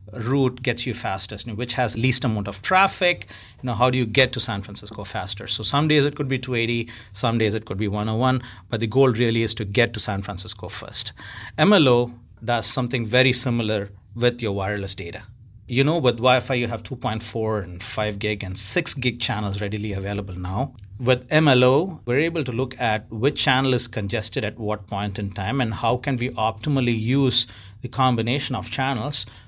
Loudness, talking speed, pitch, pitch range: -22 LUFS, 195 wpm, 115 Hz, 105-130 Hz